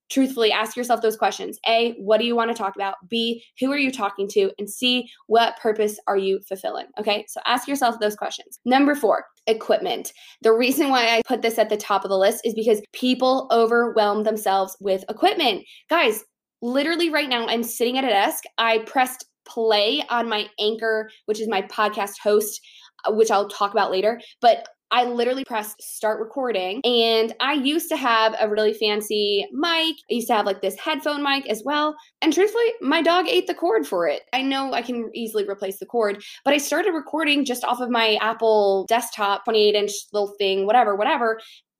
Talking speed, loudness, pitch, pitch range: 195 wpm, -21 LUFS, 225 Hz, 210-260 Hz